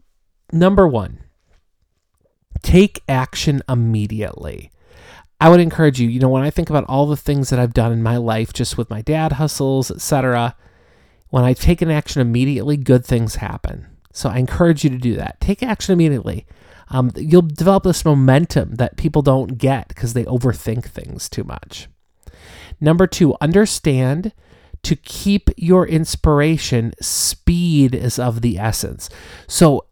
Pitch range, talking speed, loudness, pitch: 110-150 Hz, 155 wpm, -16 LUFS, 130 Hz